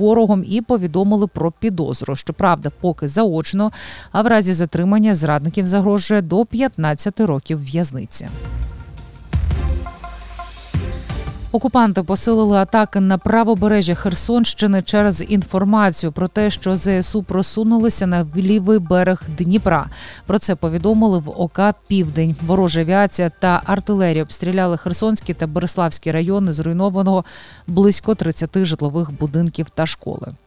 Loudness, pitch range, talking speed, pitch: -17 LUFS, 165-210 Hz, 110 wpm, 190 Hz